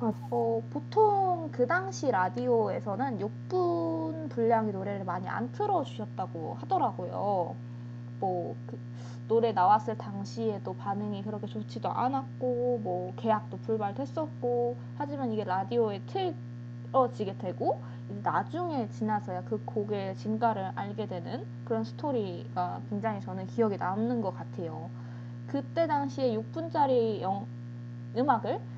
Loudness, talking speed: -31 LUFS, 270 characters per minute